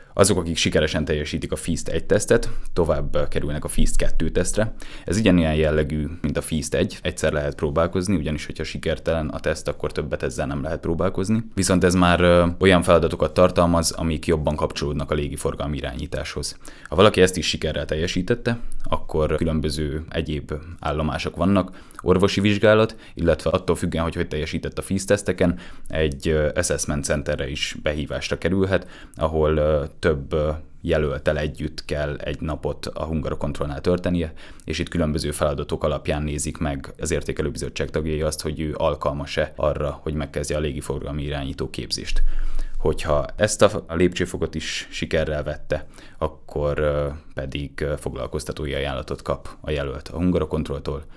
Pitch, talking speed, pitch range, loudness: 80 Hz, 140 wpm, 75-85 Hz, -23 LUFS